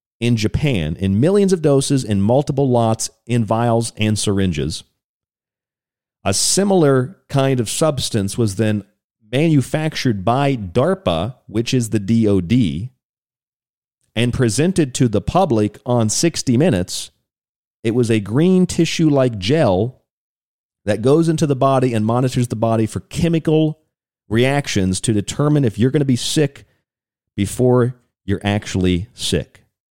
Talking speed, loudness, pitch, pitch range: 130 wpm, -17 LUFS, 120 Hz, 110-140 Hz